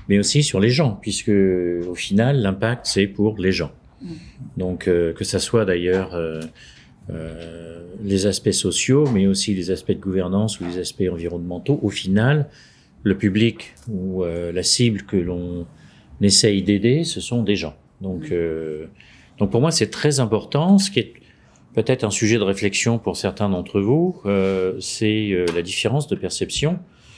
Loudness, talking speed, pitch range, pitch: -20 LUFS, 170 wpm, 90-115 Hz, 100 Hz